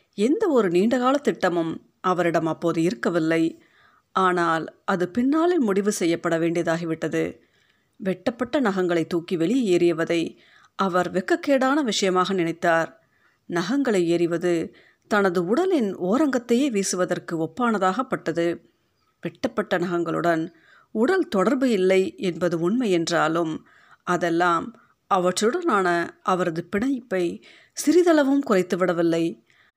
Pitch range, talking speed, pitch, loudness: 170-230 Hz, 85 wpm, 185 Hz, -23 LUFS